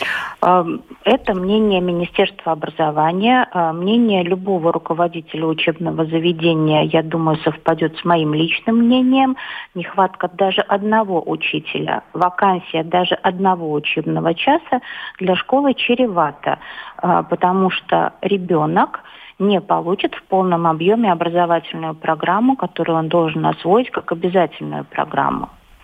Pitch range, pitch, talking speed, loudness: 165-200 Hz, 175 Hz, 105 wpm, -17 LUFS